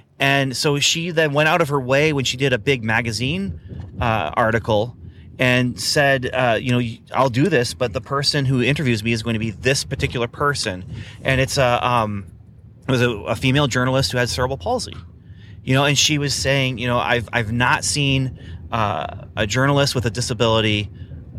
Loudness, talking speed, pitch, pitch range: -19 LUFS, 195 wpm, 125 Hz, 110-135 Hz